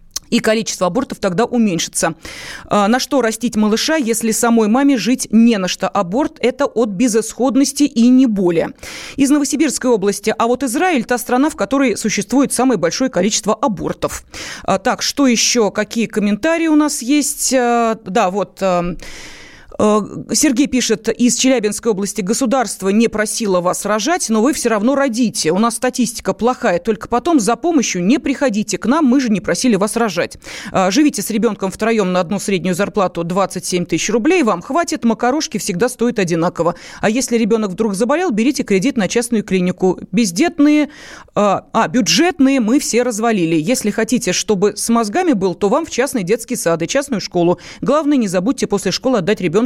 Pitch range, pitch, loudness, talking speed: 205-260 Hz, 230 Hz, -16 LUFS, 165 wpm